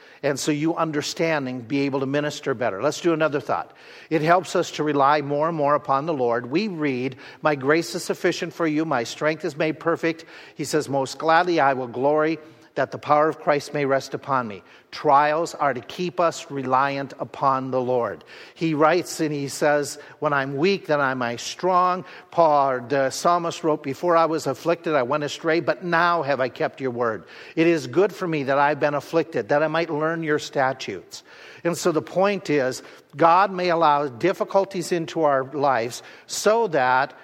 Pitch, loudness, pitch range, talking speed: 150 Hz, -22 LUFS, 140-165 Hz, 195 wpm